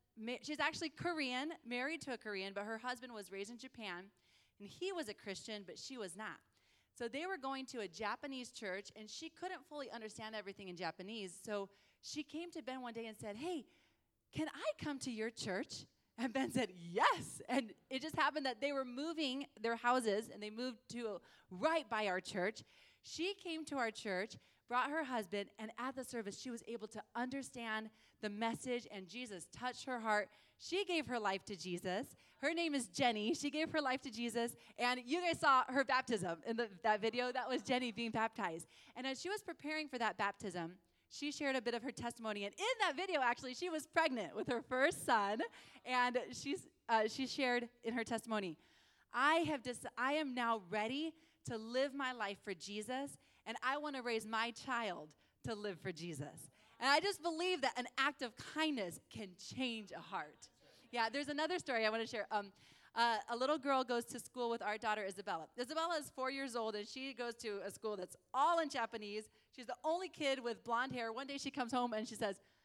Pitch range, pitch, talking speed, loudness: 215-275 Hz, 245 Hz, 210 wpm, -41 LUFS